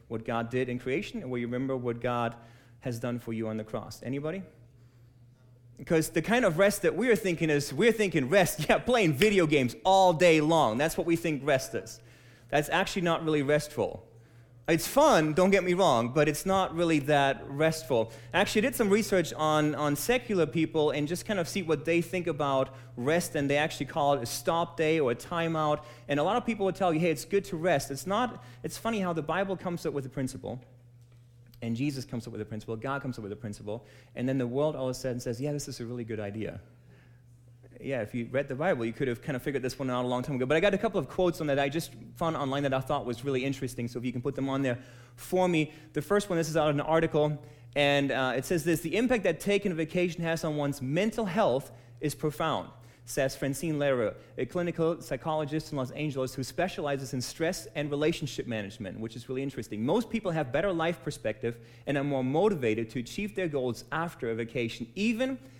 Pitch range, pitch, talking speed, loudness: 125-165 Hz, 145 Hz, 235 wpm, -29 LUFS